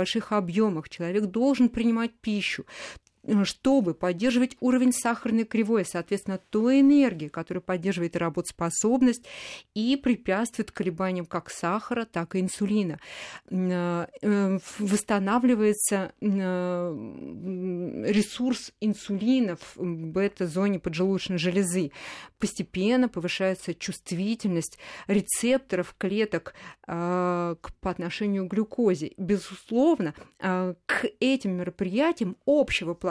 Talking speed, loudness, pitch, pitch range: 85 wpm, -27 LUFS, 200 Hz, 180-230 Hz